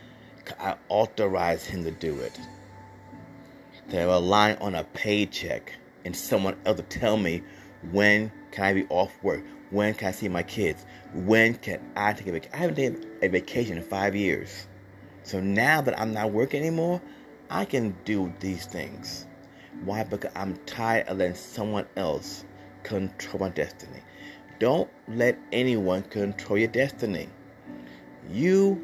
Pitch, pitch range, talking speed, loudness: 100 Hz, 95-110 Hz, 150 wpm, -27 LUFS